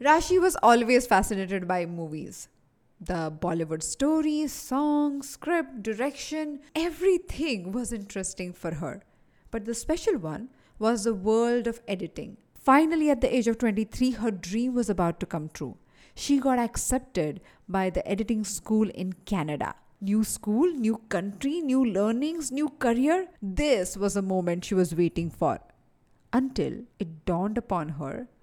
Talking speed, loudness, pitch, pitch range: 145 wpm, -27 LUFS, 225 Hz, 190-275 Hz